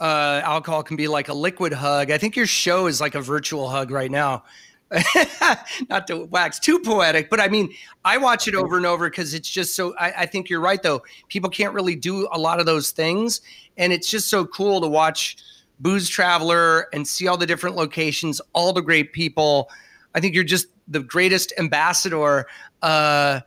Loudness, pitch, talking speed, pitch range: -20 LUFS, 170 Hz, 200 wpm, 155-185 Hz